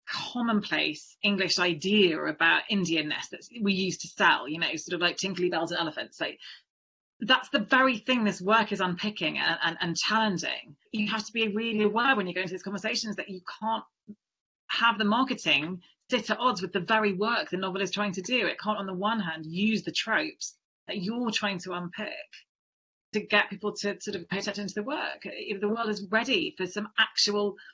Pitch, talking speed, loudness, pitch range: 205 Hz, 205 wpm, -28 LUFS, 185-220 Hz